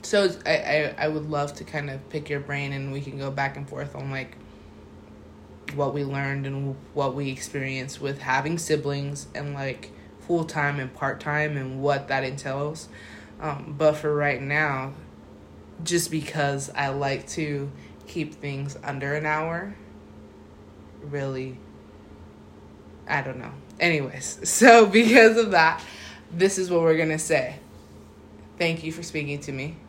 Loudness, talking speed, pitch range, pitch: -24 LUFS, 155 wpm, 130-155 Hz, 140 Hz